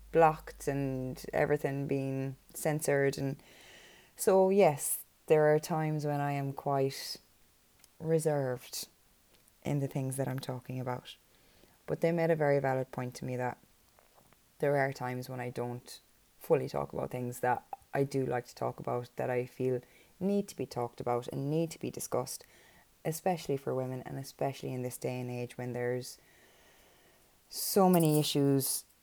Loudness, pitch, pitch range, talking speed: -33 LUFS, 135 Hz, 125-150 Hz, 160 wpm